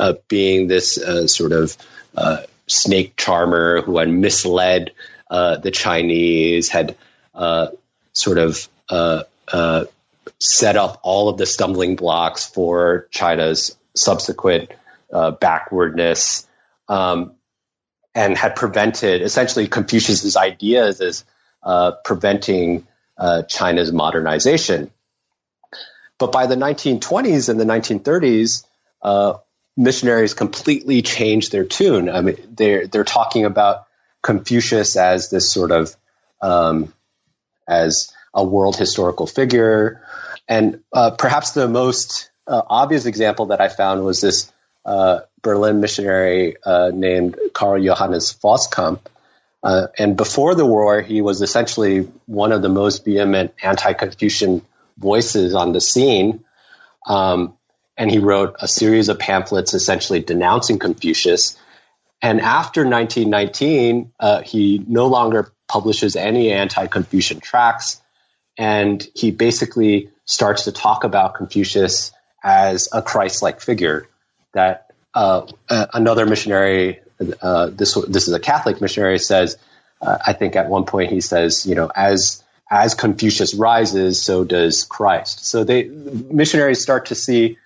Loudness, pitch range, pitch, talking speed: -17 LUFS, 90-115 Hz, 100 Hz, 130 wpm